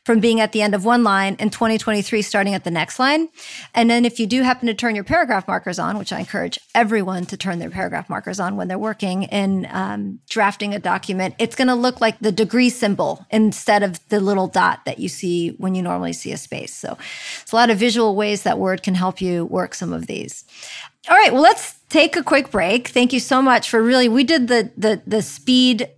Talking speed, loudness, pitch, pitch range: 235 wpm, -18 LUFS, 220 Hz, 195-245 Hz